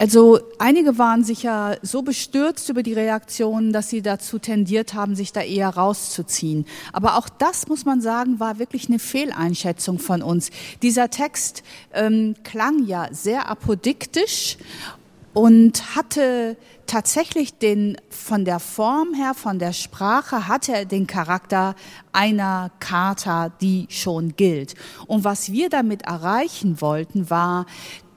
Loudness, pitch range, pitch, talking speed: -20 LUFS, 190-245 Hz, 215 Hz, 135 wpm